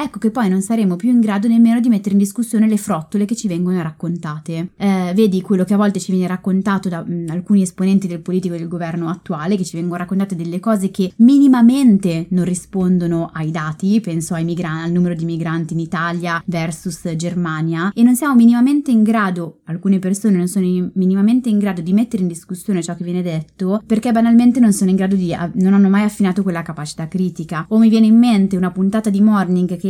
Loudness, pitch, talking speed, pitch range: -16 LUFS, 190 Hz, 215 wpm, 175-210 Hz